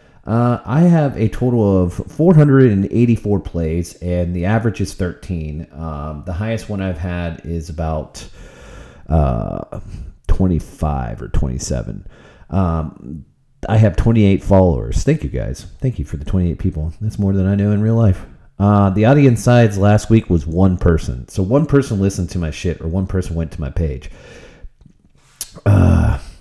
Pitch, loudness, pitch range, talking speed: 95 Hz, -17 LUFS, 80-105 Hz, 160 wpm